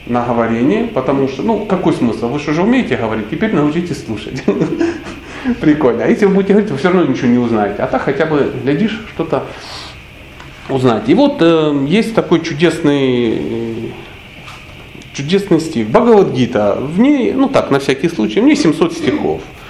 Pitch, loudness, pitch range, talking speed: 160 Hz, -14 LUFS, 125-205 Hz, 170 wpm